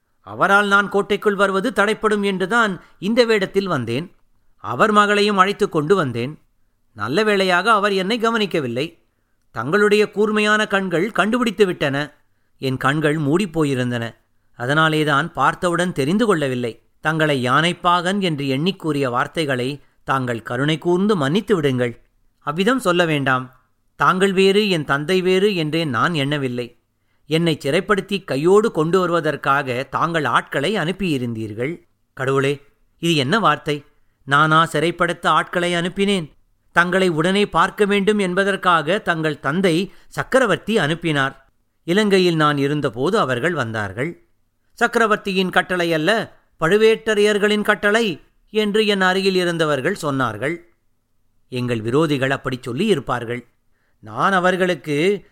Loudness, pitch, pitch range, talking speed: -18 LUFS, 160 Hz, 130-195 Hz, 110 wpm